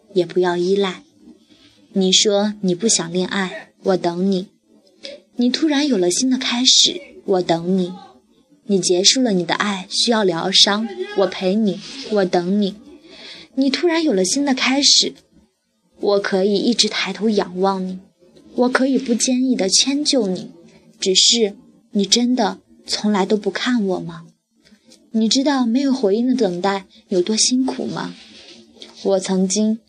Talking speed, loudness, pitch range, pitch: 205 characters per minute, -17 LUFS, 190-250 Hz, 205 Hz